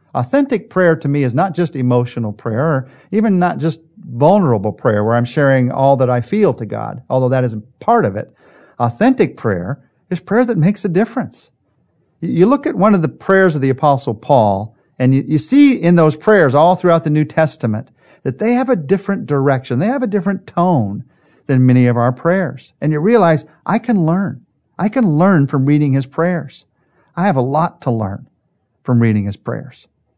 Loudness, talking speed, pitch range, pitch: -15 LUFS, 200 wpm, 130-190 Hz, 150 Hz